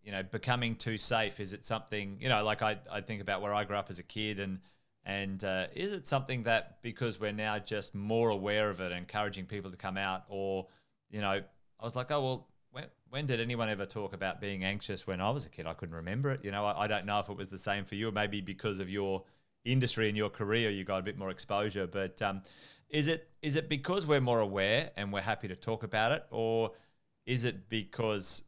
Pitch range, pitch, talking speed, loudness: 95-115 Hz, 105 Hz, 245 wpm, -34 LUFS